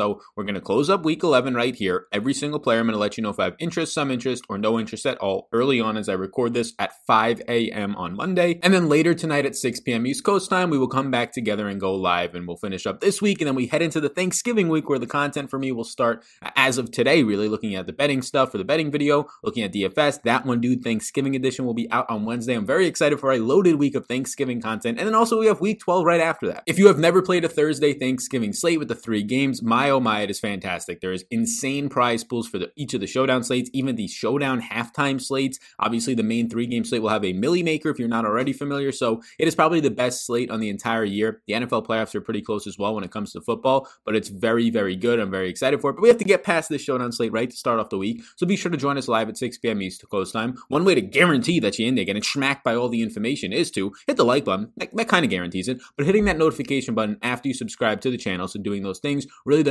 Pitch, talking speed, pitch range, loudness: 125 Hz, 280 wpm, 110-150 Hz, -22 LUFS